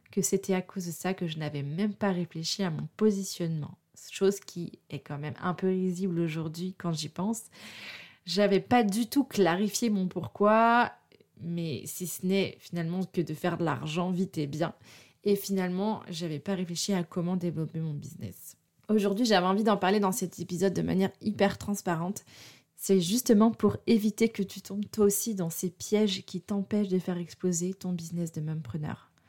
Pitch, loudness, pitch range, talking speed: 185 Hz, -29 LUFS, 170-200 Hz, 190 wpm